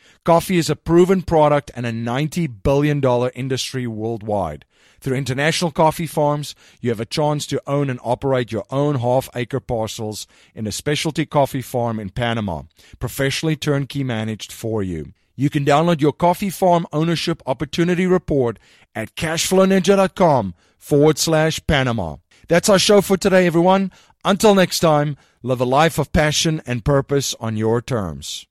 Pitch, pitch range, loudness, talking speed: 140 Hz, 115-160 Hz, -19 LUFS, 155 wpm